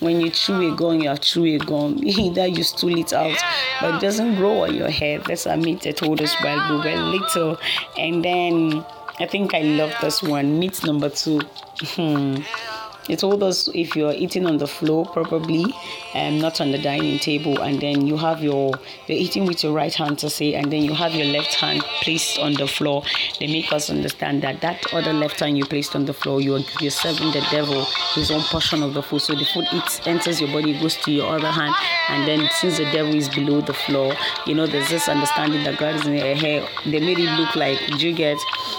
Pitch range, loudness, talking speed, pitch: 145-170 Hz, -20 LUFS, 230 wpm, 155 Hz